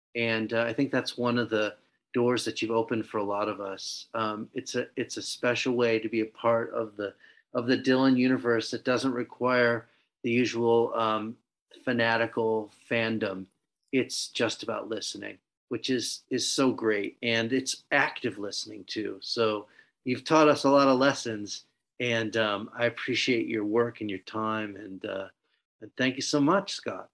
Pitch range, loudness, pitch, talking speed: 110-125 Hz, -28 LUFS, 115 Hz, 180 wpm